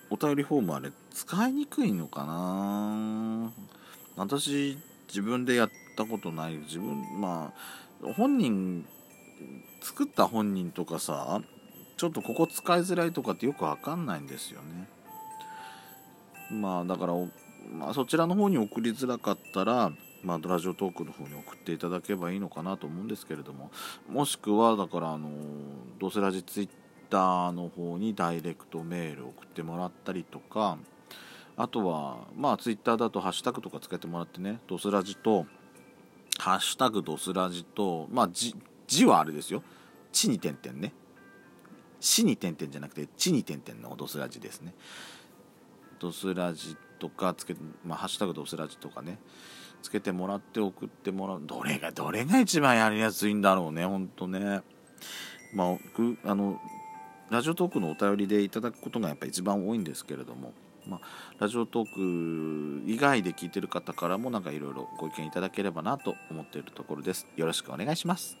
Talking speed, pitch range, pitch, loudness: 340 characters per minute, 85-115 Hz, 100 Hz, -31 LUFS